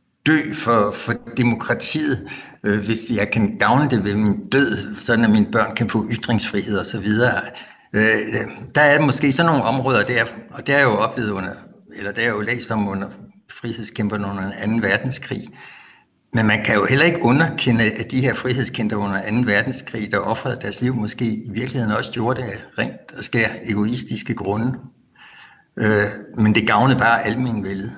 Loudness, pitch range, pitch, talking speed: -19 LUFS, 105-125 Hz, 115 Hz, 180 wpm